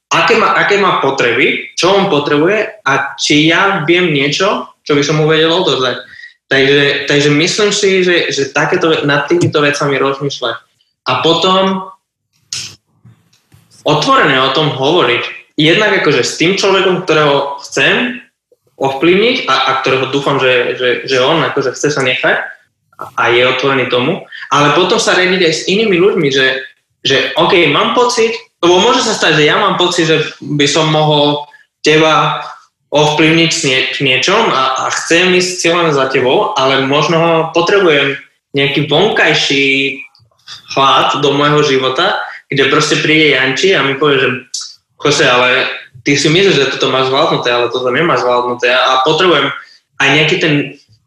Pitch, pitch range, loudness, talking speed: 150 Hz, 135-180 Hz, -11 LUFS, 155 wpm